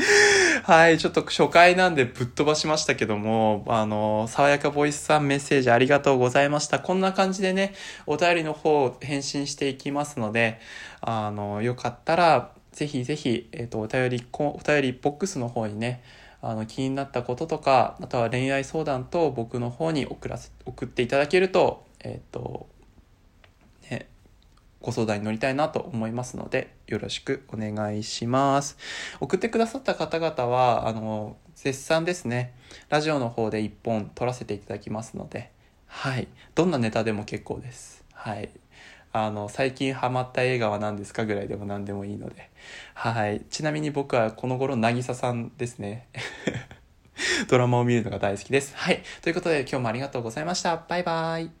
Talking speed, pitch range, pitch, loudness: 350 characters per minute, 115-150 Hz, 125 Hz, -25 LUFS